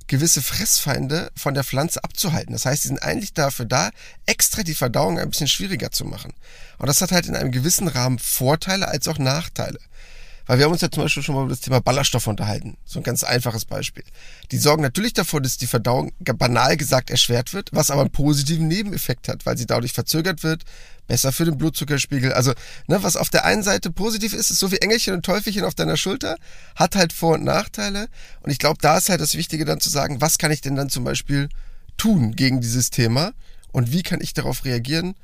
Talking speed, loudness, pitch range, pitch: 220 wpm, -20 LUFS, 130-170 Hz, 145 Hz